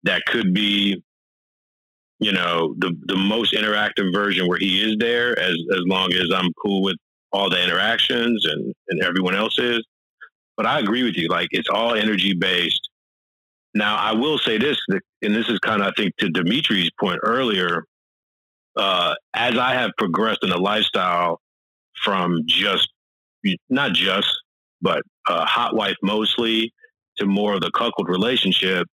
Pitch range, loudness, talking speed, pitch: 95-110 Hz, -20 LUFS, 160 wpm, 100 Hz